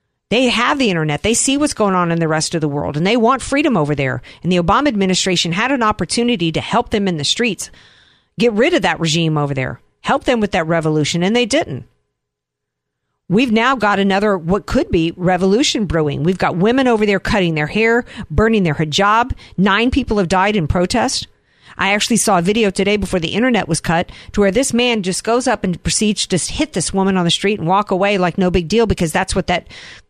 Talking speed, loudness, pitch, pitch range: 225 wpm, -16 LUFS, 195 Hz, 170-225 Hz